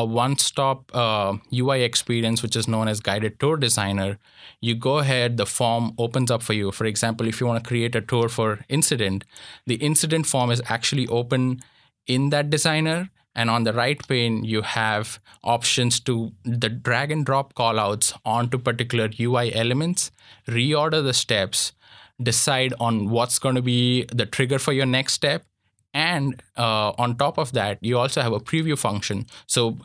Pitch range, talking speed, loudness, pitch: 115-135 Hz, 175 wpm, -22 LUFS, 120 Hz